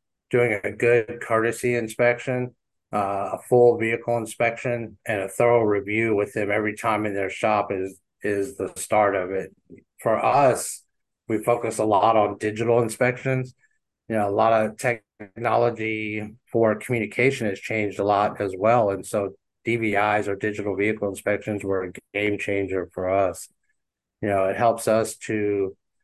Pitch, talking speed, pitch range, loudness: 110 Hz, 160 wpm, 100-120 Hz, -23 LUFS